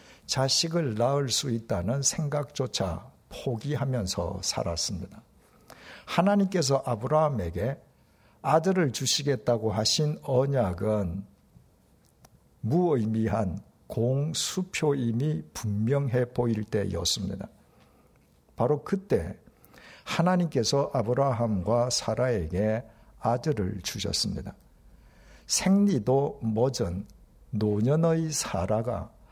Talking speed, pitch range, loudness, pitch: 210 characters per minute, 105-145 Hz, -27 LUFS, 120 Hz